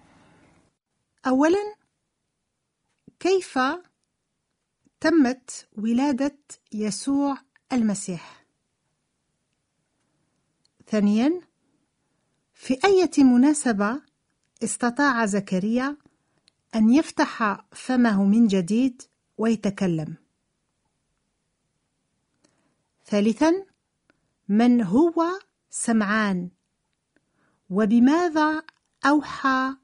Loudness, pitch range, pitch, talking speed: -23 LUFS, 215-295 Hz, 255 Hz, 50 wpm